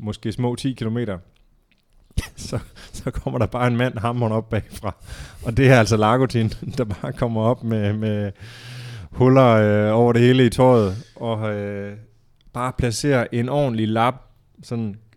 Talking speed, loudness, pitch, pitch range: 160 wpm, -20 LUFS, 115 Hz, 110-125 Hz